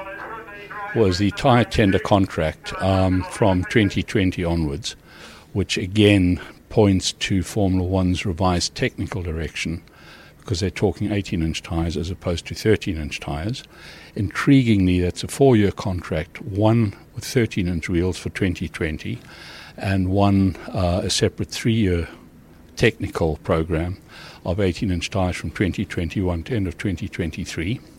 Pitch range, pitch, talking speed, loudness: 85-105 Hz, 95 Hz, 120 wpm, -22 LUFS